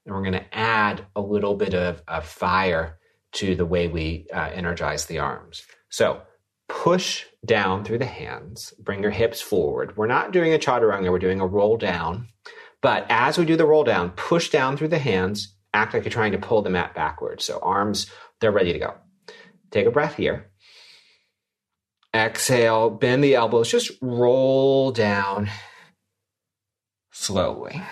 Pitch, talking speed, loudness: 115 Hz, 170 wpm, -22 LUFS